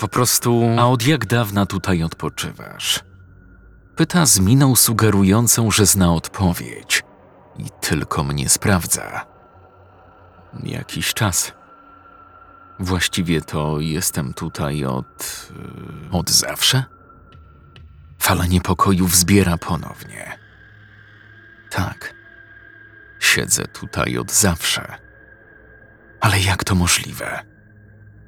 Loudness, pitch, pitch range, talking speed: -18 LUFS, 100 Hz, 90-115 Hz, 90 wpm